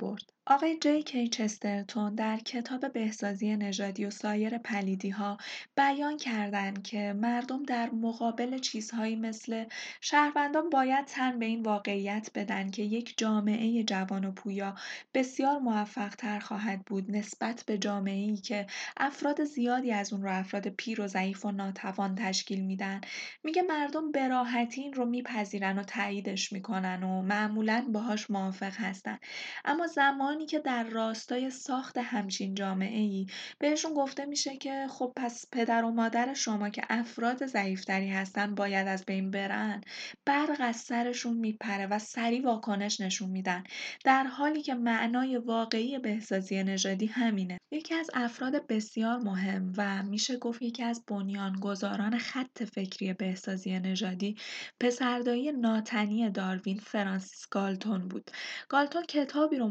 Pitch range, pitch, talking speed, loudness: 200-250 Hz, 220 Hz, 140 wpm, -32 LUFS